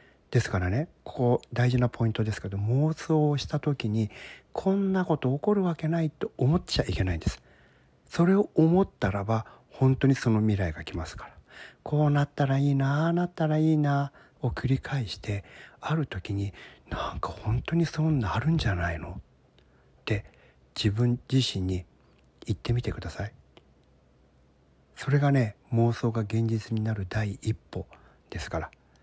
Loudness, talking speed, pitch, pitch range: -28 LUFS, 315 characters per minute, 115 Hz, 95-145 Hz